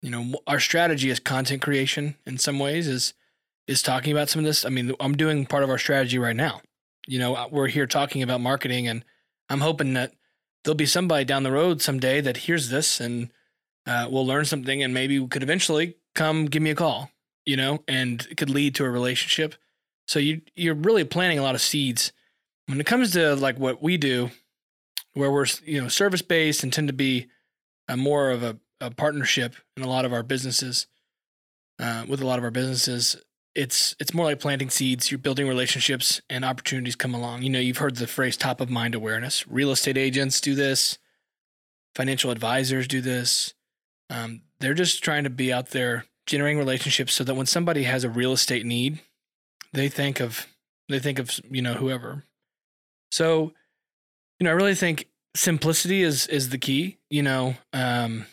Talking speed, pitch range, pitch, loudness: 195 wpm, 125-150 Hz, 135 Hz, -24 LUFS